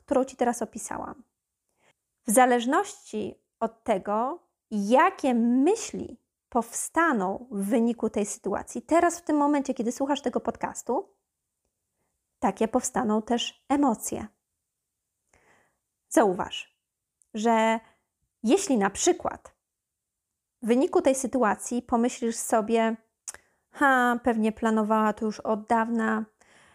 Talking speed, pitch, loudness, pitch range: 100 wpm, 235 Hz, -26 LUFS, 225-270 Hz